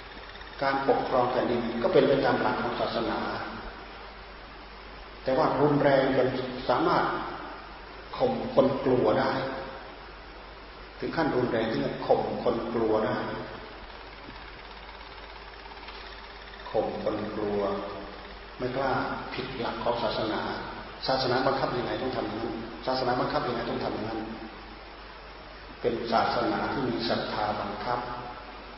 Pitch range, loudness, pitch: 110-130 Hz, -28 LUFS, 120 Hz